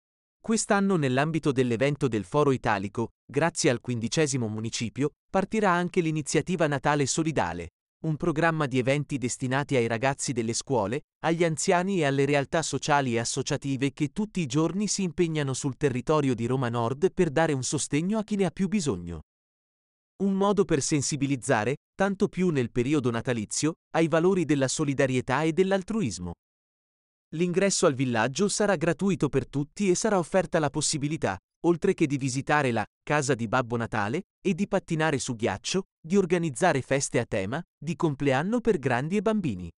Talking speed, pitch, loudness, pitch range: 160 wpm, 150 Hz, -26 LUFS, 130-180 Hz